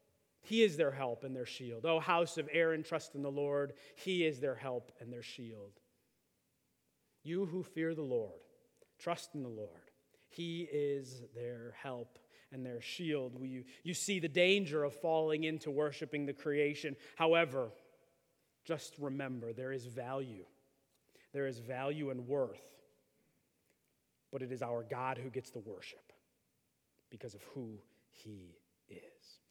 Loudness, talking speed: -38 LUFS, 150 wpm